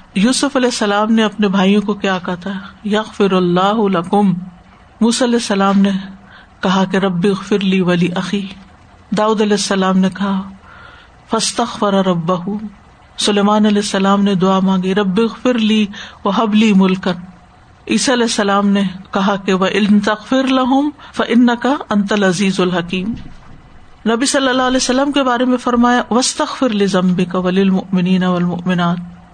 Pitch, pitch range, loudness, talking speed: 205 Hz, 190-230 Hz, -15 LUFS, 135 wpm